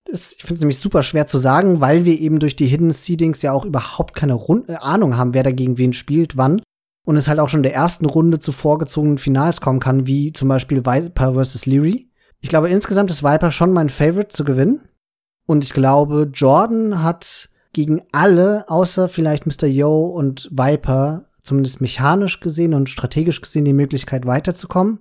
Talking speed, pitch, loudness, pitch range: 195 wpm, 150 Hz, -16 LUFS, 135-170 Hz